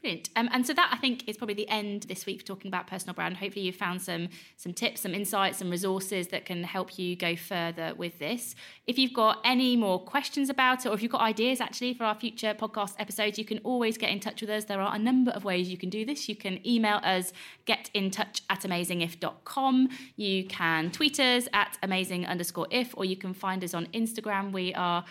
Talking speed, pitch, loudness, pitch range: 230 wpm, 205 Hz, -29 LUFS, 185-230 Hz